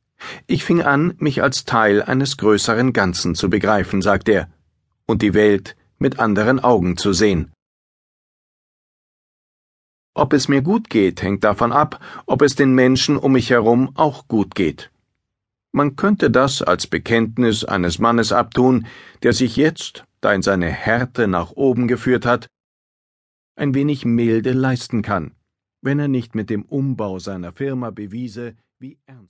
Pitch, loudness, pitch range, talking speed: 115 Hz, -17 LUFS, 105-135 Hz, 150 wpm